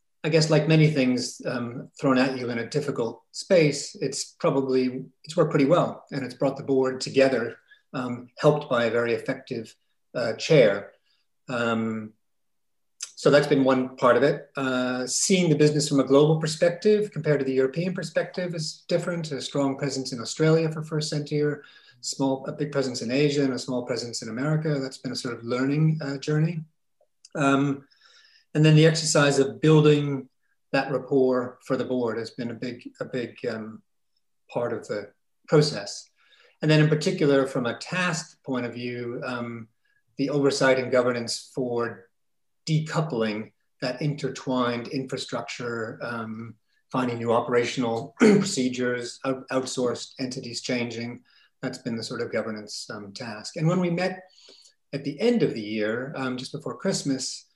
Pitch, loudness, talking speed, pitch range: 135 Hz, -25 LUFS, 165 wpm, 125-150 Hz